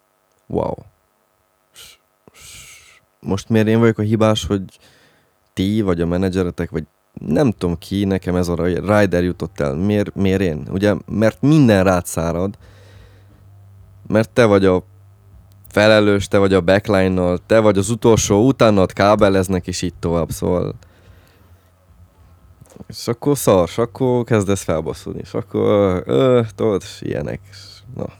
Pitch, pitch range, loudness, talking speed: 100 Hz, 90-105 Hz, -17 LUFS, 140 wpm